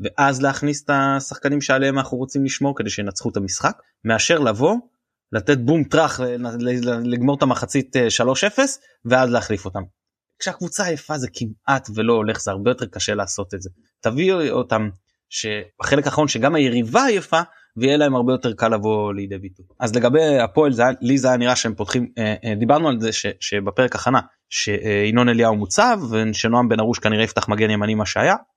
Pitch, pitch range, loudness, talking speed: 120 Hz, 110-140 Hz, -19 LUFS, 170 wpm